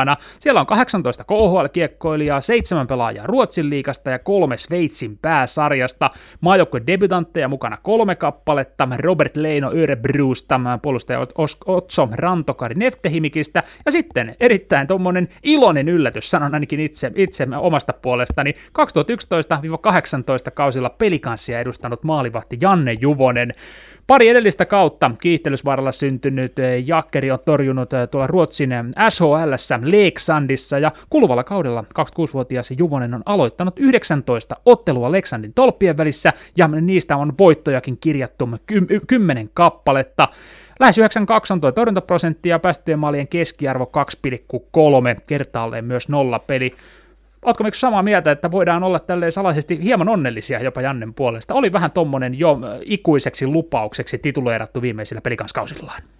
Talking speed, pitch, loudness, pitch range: 115 wpm, 150 Hz, -18 LUFS, 130-180 Hz